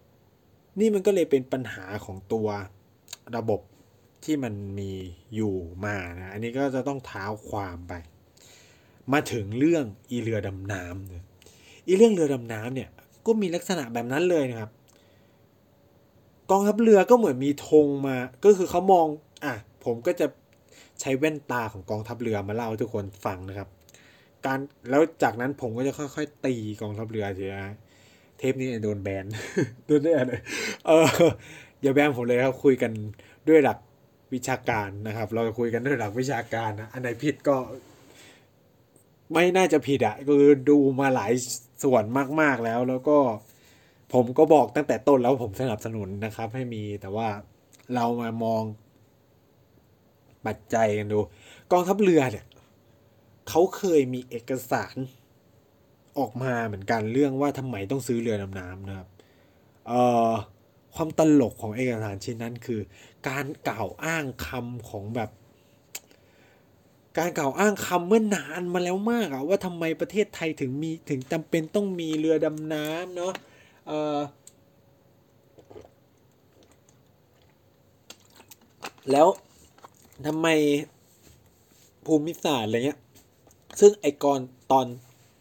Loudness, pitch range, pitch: -25 LUFS, 110-145 Hz, 125 Hz